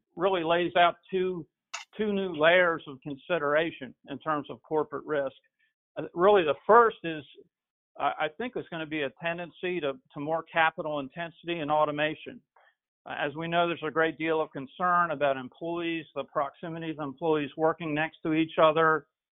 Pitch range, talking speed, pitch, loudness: 150-175 Hz, 165 wpm, 160 Hz, -28 LUFS